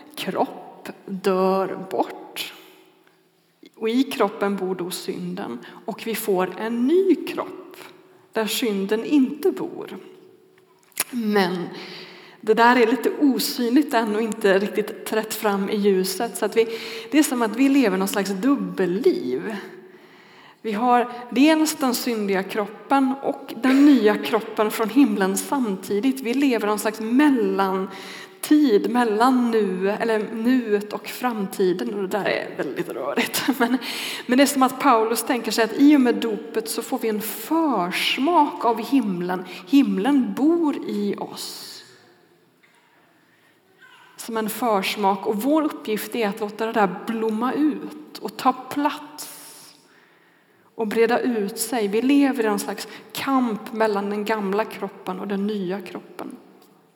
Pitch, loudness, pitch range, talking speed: 225 Hz, -22 LUFS, 205-275 Hz, 140 wpm